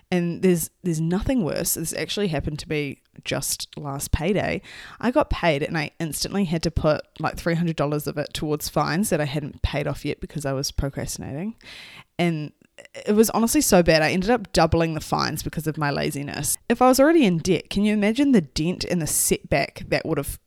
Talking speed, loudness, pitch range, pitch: 215 wpm, -23 LUFS, 150-200 Hz, 165 Hz